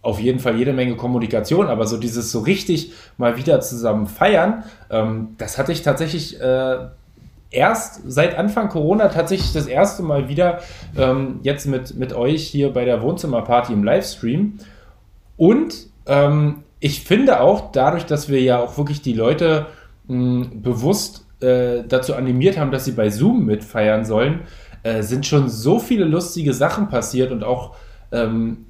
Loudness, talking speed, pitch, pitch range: -19 LUFS, 160 wpm, 130 Hz, 120-160 Hz